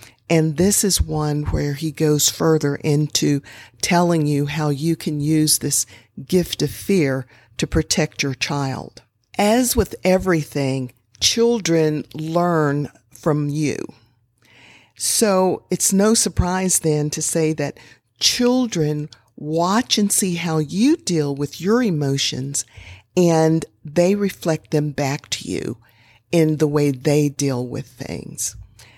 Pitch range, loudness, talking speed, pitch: 135-170 Hz, -19 LUFS, 130 wpm, 150 Hz